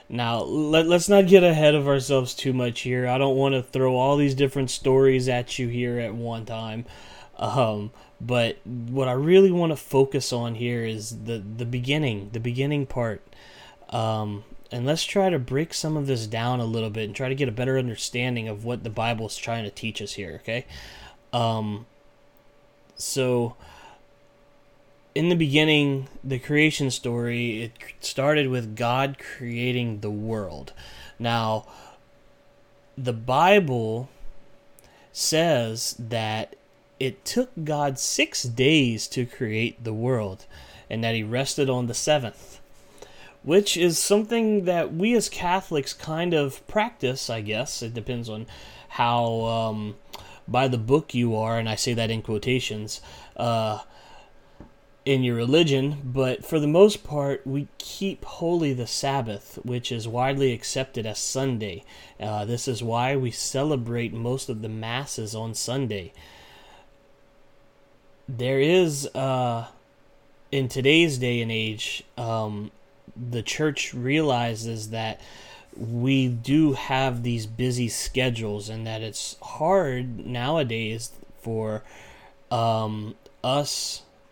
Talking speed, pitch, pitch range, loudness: 140 wpm, 125 Hz, 115-140 Hz, -24 LUFS